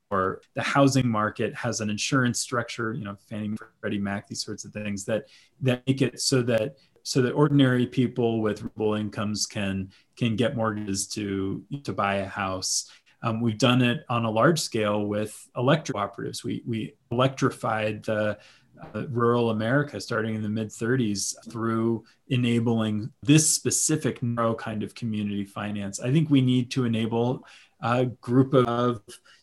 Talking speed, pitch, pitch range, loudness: 165 wpm, 115 Hz, 105-125 Hz, -26 LUFS